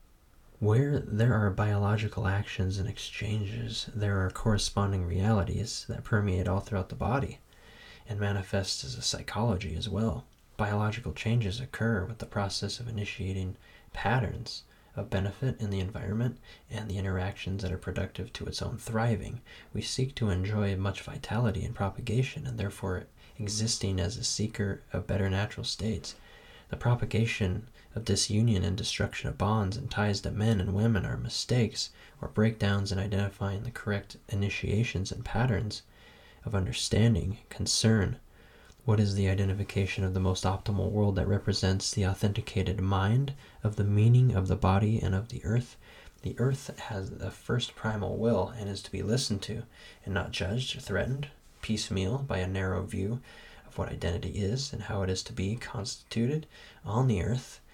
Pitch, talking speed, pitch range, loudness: 105 Hz, 160 wpm, 95-115 Hz, -31 LUFS